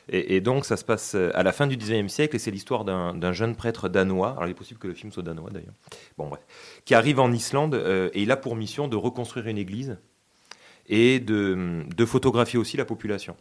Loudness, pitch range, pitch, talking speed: -25 LUFS, 95-125 Hz, 110 Hz, 235 wpm